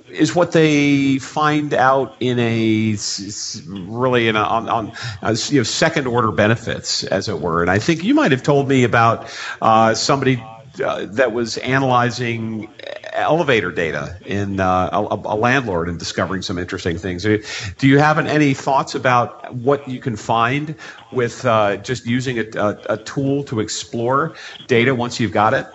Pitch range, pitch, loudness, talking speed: 105-135 Hz, 120 Hz, -18 LUFS, 170 wpm